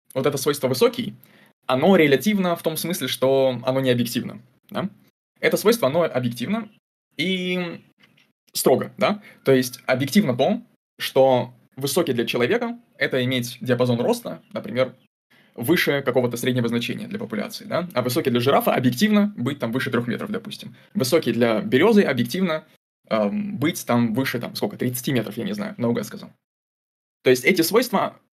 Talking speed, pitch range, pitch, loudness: 155 wpm, 125-195 Hz, 135 Hz, -22 LUFS